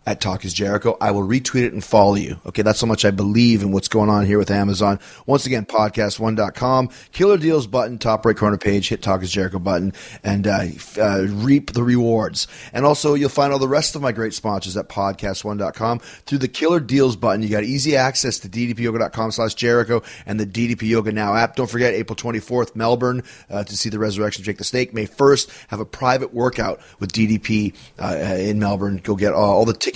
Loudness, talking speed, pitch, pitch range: -19 LUFS, 210 wpm, 110 Hz, 100-125 Hz